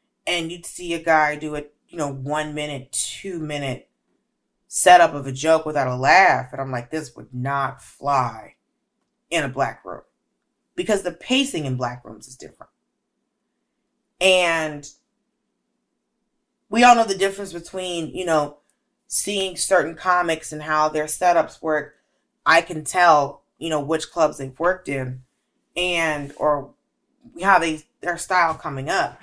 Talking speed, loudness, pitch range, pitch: 150 wpm, -21 LUFS, 145-180 Hz, 160 Hz